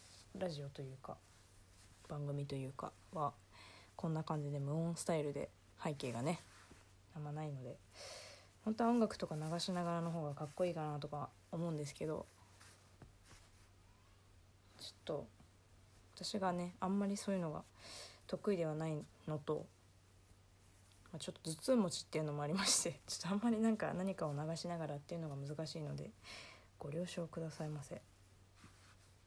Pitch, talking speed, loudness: 145 Hz, 320 characters per minute, -42 LUFS